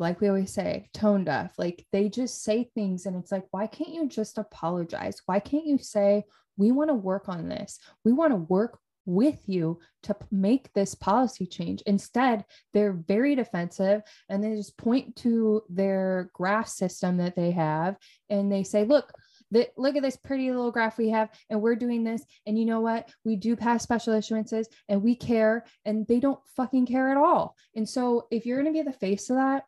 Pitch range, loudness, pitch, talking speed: 195-245 Hz, -27 LUFS, 220 Hz, 205 wpm